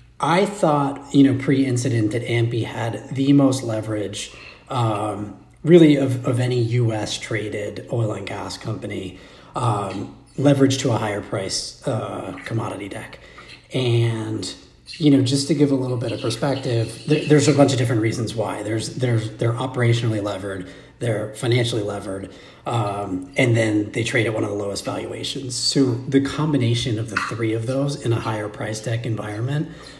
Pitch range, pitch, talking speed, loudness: 110-135 Hz, 120 Hz, 170 wpm, -21 LUFS